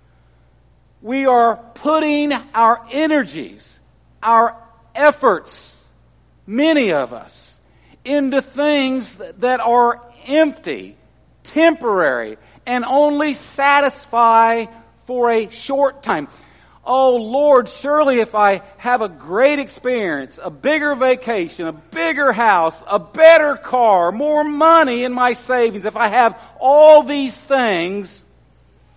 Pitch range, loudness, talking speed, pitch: 220-285 Hz, -15 LUFS, 110 wpm, 250 Hz